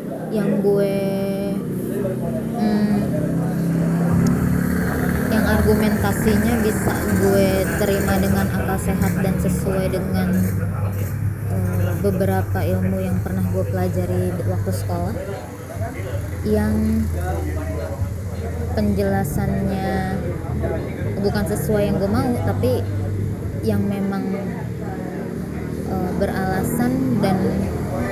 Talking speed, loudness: 75 wpm, -21 LUFS